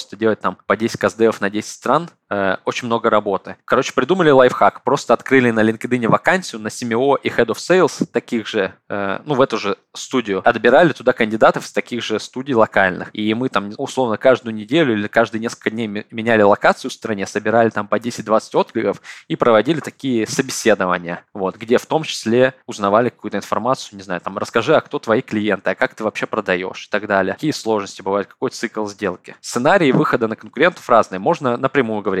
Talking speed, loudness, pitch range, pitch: 190 wpm, -18 LUFS, 105-125 Hz, 110 Hz